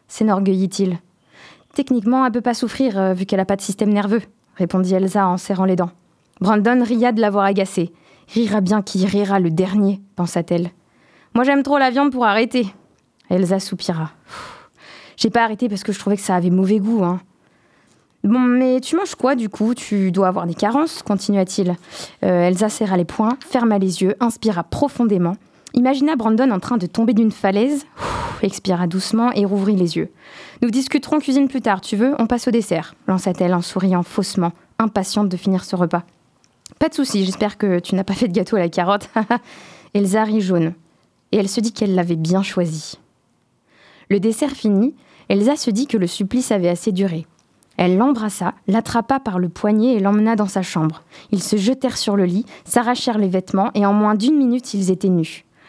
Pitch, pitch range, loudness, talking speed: 205 Hz, 185-235 Hz, -18 LUFS, 190 wpm